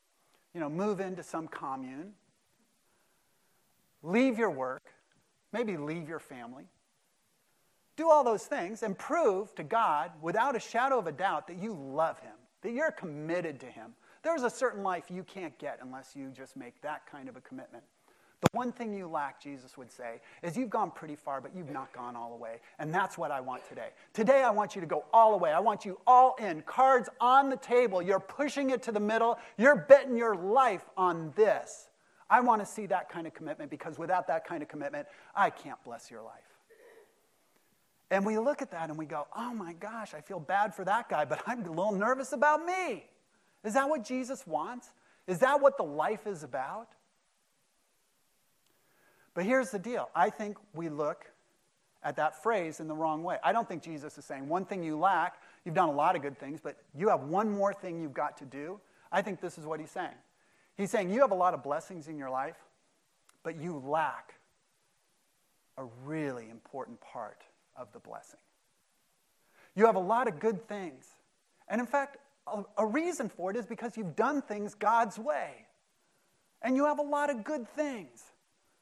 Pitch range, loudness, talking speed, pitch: 155-240 Hz, -31 LUFS, 200 wpm, 195 Hz